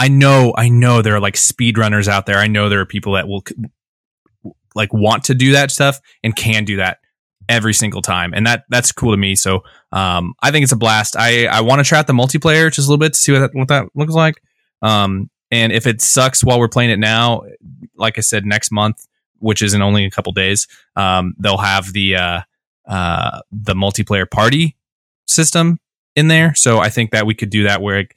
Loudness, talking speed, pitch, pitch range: -13 LUFS, 230 wpm, 110 Hz, 100-130 Hz